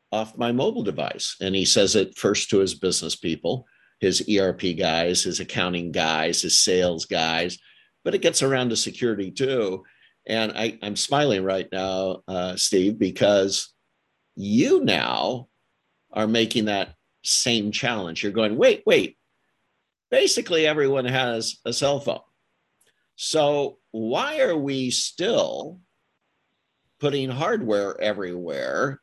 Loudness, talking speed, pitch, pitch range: -23 LUFS, 130 wpm, 110 Hz, 95-135 Hz